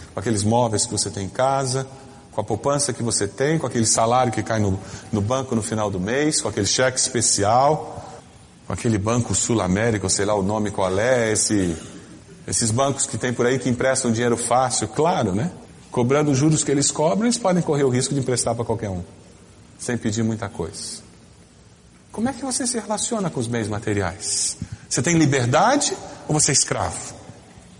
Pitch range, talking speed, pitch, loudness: 105-135 Hz, 190 wpm, 120 Hz, -21 LUFS